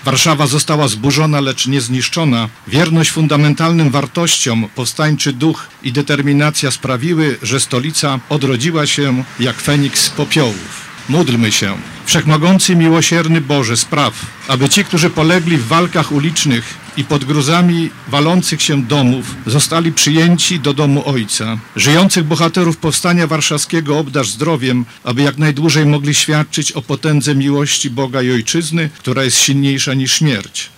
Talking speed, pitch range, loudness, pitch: 130 wpm, 135-160 Hz, -13 LUFS, 145 Hz